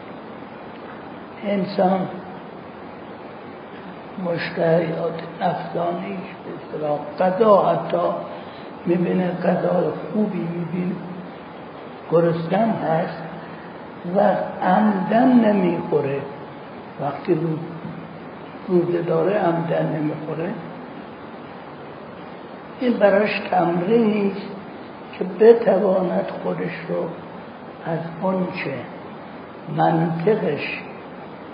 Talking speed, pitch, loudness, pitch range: 55 wpm, 180 Hz, -21 LUFS, 165-200 Hz